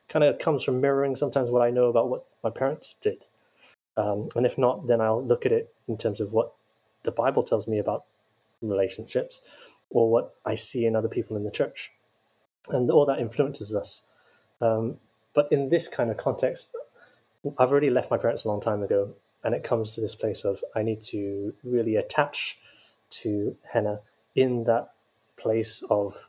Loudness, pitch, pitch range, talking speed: -26 LUFS, 120 Hz, 110-140 Hz, 185 wpm